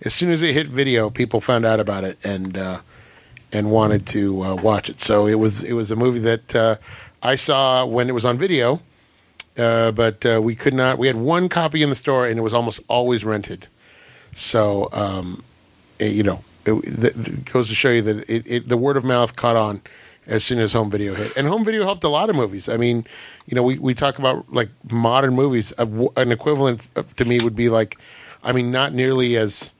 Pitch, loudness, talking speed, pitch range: 120 Hz, -19 LUFS, 230 wpm, 110-130 Hz